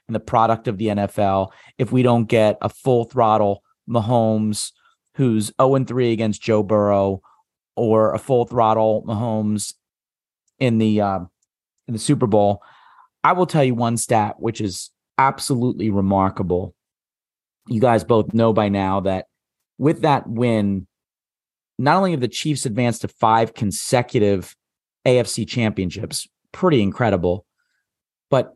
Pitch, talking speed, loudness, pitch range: 110 Hz, 135 wpm, -19 LUFS, 100-125 Hz